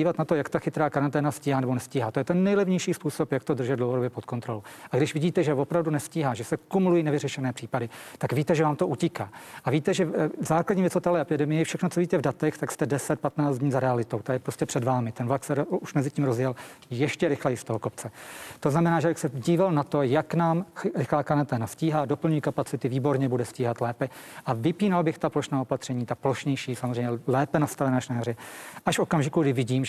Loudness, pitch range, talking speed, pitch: -27 LUFS, 130-165 Hz, 220 wpm, 145 Hz